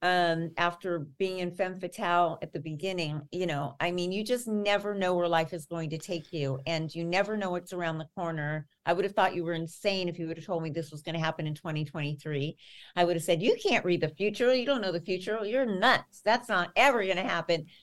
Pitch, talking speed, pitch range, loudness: 175 Hz, 250 wpm, 160-190 Hz, -30 LUFS